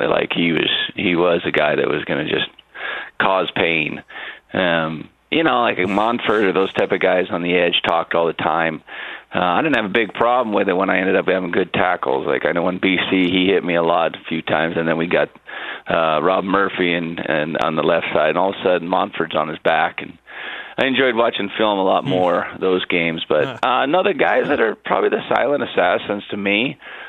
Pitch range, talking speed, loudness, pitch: 85-100 Hz, 230 wpm, -18 LUFS, 90 Hz